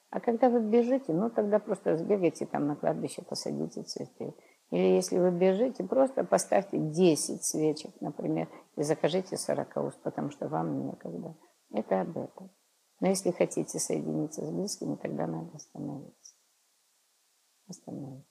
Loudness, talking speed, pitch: -30 LUFS, 140 wpm, 160 Hz